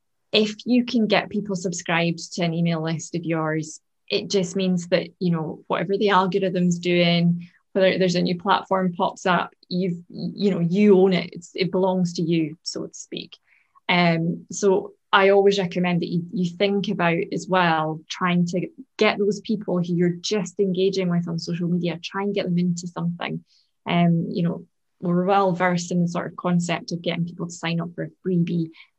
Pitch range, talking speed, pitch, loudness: 175-195 Hz, 195 wpm, 180 Hz, -23 LUFS